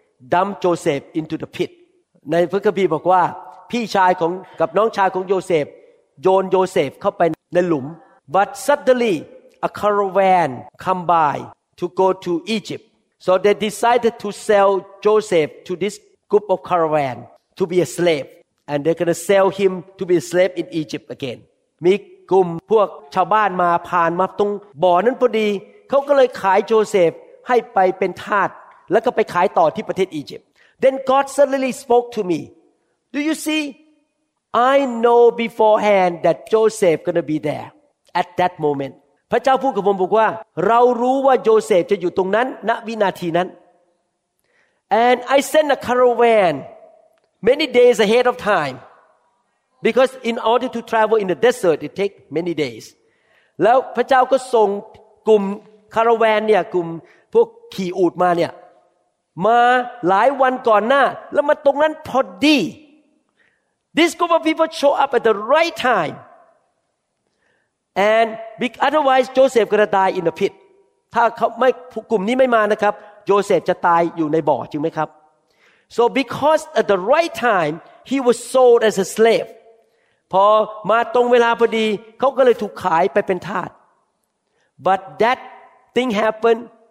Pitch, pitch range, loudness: 215 Hz, 180-250 Hz, -17 LUFS